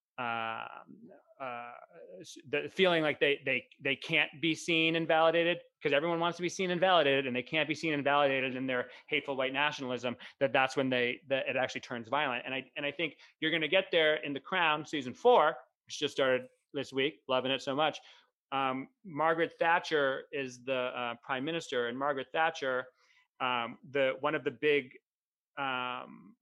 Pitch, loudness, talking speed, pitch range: 145 Hz, -31 LUFS, 190 wpm, 130-160 Hz